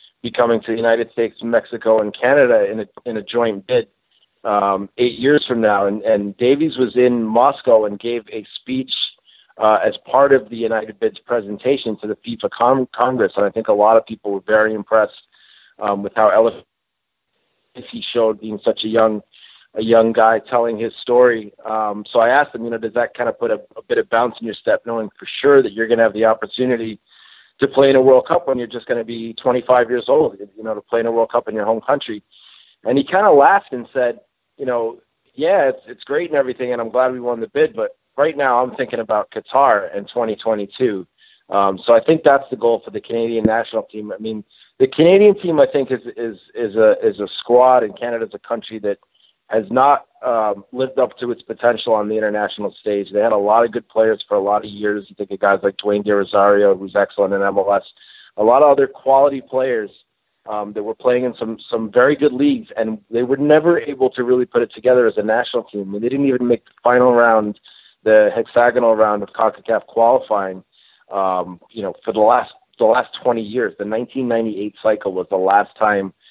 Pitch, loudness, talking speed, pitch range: 115 Hz, -17 LUFS, 225 wpm, 105-125 Hz